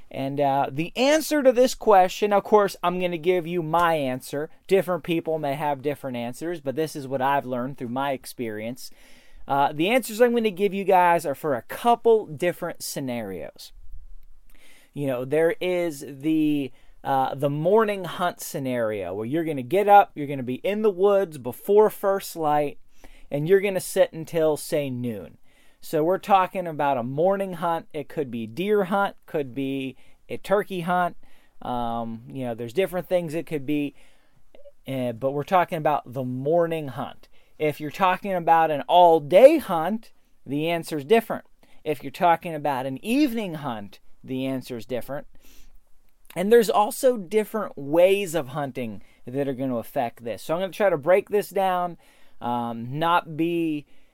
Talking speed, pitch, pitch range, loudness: 175 wpm, 165 Hz, 140-195 Hz, -24 LUFS